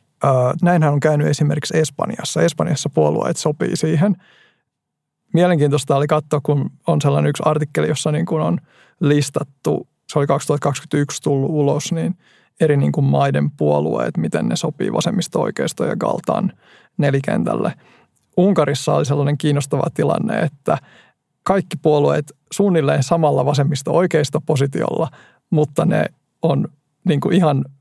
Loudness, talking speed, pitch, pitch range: -18 LUFS, 125 wpm, 150 Hz, 145-165 Hz